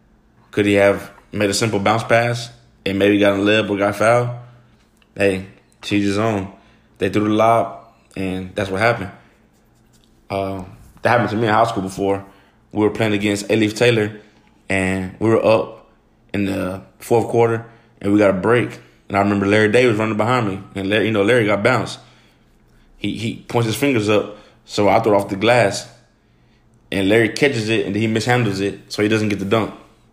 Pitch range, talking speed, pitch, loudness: 100-115 Hz, 195 wpm, 105 Hz, -18 LUFS